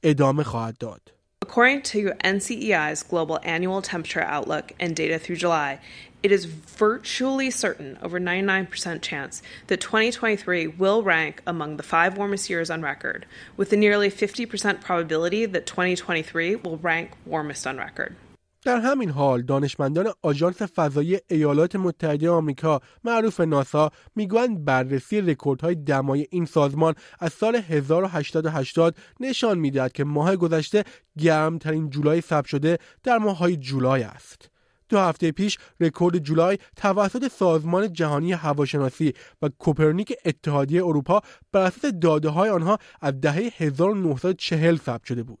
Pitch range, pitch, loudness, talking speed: 150-200 Hz, 170 Hz, -23 LUFS, 130 wpm